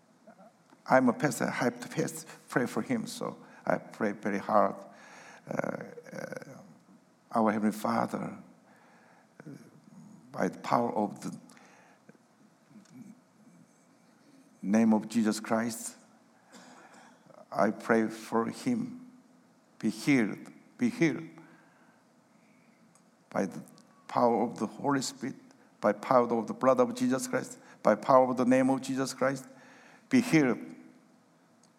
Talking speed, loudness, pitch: 115 wpm, -30 LUFS, 135 Hz